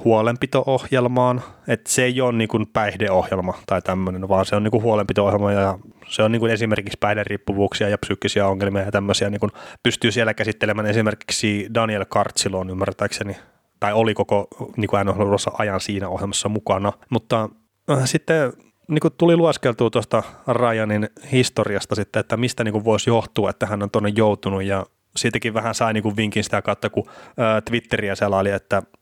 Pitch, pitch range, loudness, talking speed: 110 Hz, 100-115 Hz, -21 LUFS, 170 wpm